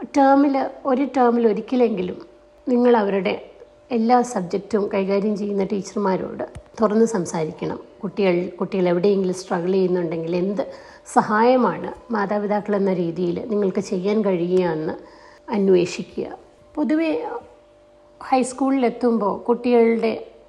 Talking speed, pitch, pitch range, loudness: 90 wpm, 210 Hz, 190-245 Hz, -21 LUFS